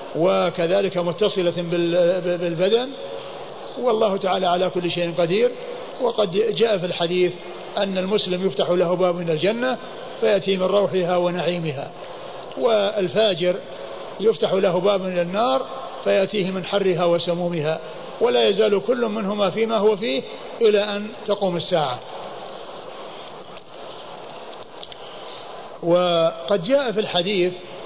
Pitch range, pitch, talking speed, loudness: 175-220 Hz, 190 Hz, 105 wpm, -21 LUFS